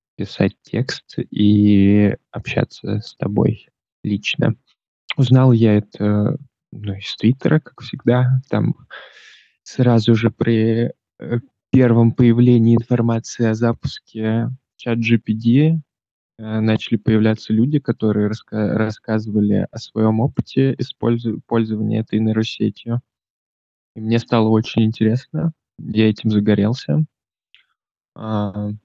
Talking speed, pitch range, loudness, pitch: 95 wpm, 110-120 Hz, -18 LUFS, 115 Hz